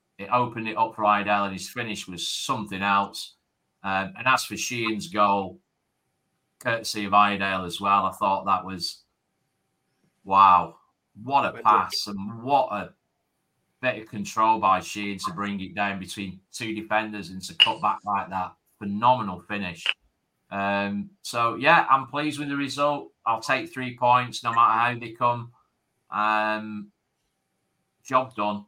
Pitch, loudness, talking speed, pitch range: 105 Hz, -24 LUFS, 155 wpm, 100-120 Hz